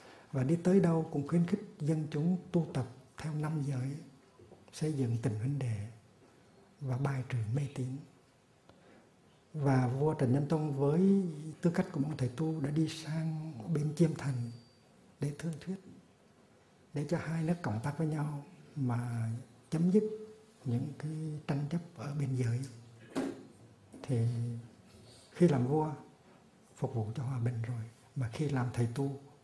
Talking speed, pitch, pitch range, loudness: 160 wpm, 145 Hz, 125-160 Hz, -35 LUFS